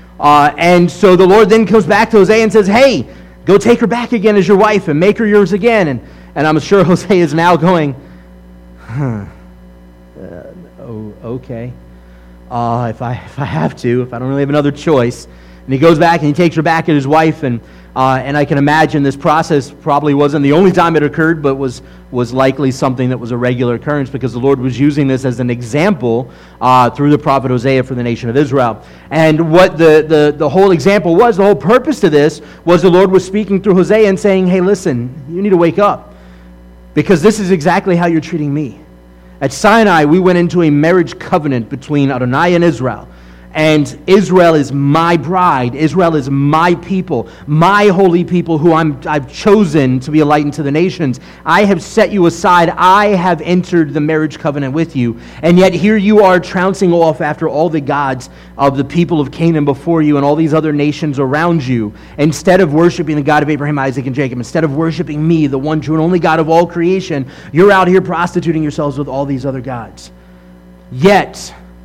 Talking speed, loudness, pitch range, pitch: 210 wpm, -11 LUFS, 130-180 Hz, 150 Hz